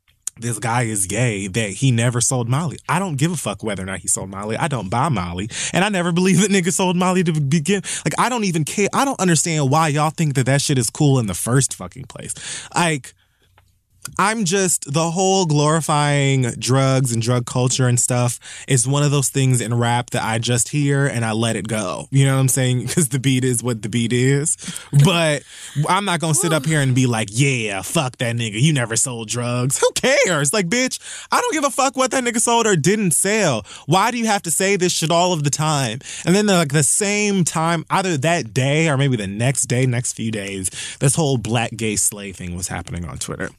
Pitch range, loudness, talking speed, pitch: 120-170 Hz, -18 LUFS, 235 wpm, 140 Hz